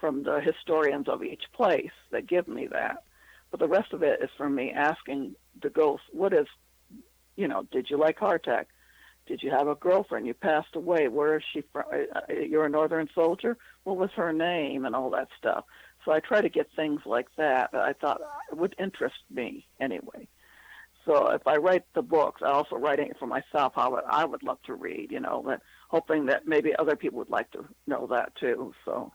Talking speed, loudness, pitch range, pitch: 210 wpm, -28 LUFS, 155-190 Hz, 160 Hz